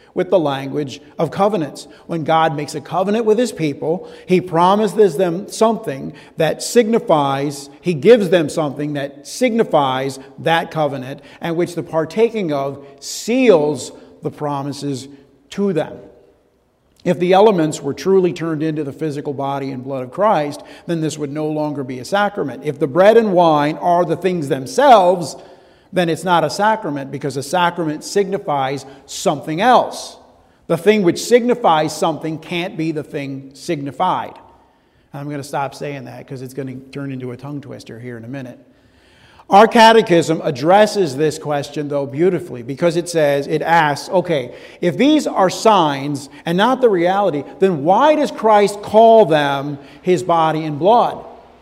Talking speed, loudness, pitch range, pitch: 160 wpm, -16 LUFS, 140-185 Hz, 160 Hz